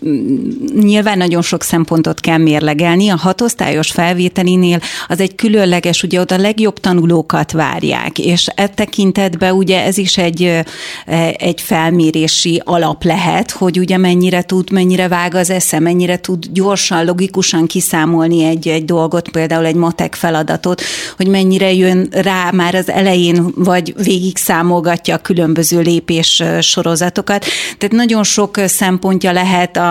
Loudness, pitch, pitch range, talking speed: -12 LUFS, 180 Hz, 170-190 Hz, 140 wpm